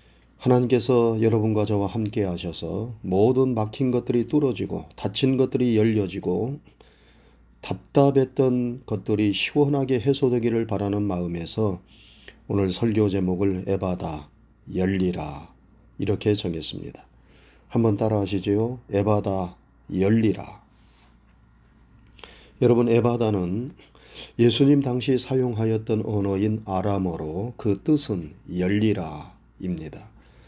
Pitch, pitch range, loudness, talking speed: 105 Hz, 95-120 Hz, -24 LUFS, 250 characters per minute